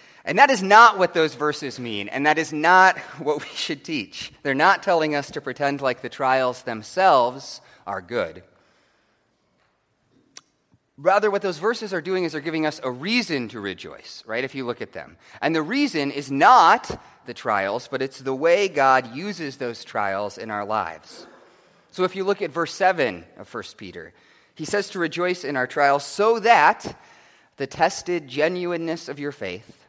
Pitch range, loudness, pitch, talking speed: 135-185 Hz, -21 LUFS, 155 Hz, 185 wpm